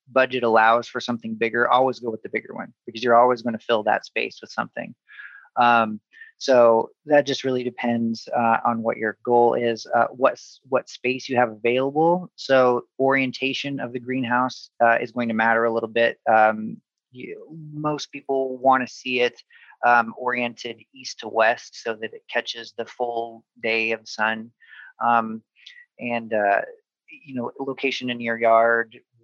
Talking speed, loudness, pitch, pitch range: 170 wpm, -22 LUFS, 120 Hz, 115-130 Hz